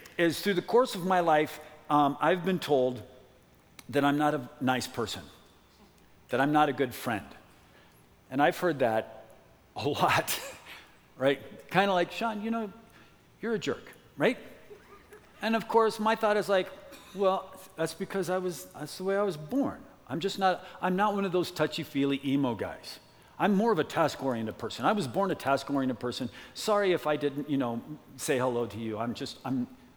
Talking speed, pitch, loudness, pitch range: 180 wpm, 150 Hz, -29 LUFS, 130-190 Hz